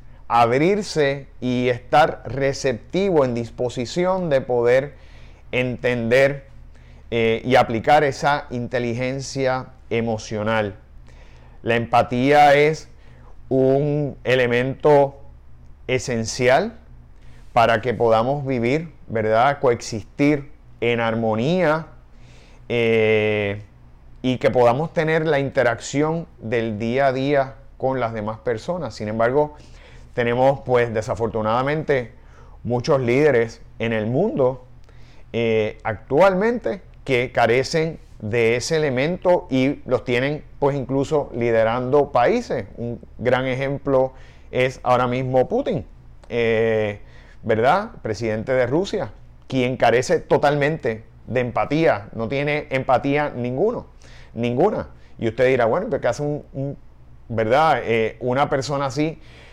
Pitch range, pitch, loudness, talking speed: 110-135 Hz, 120 Hz, -20 LUFS, 105 wpm